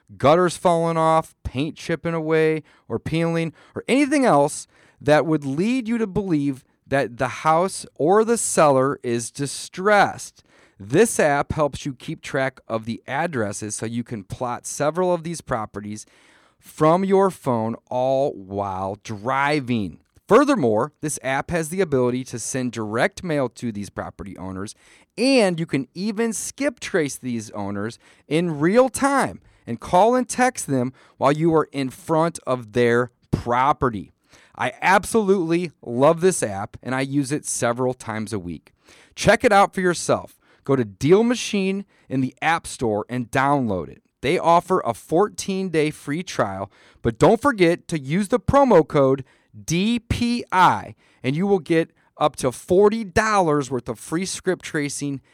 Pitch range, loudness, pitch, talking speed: 120-180 Hz, -21 LUFS, 145 Hz, 155 wpm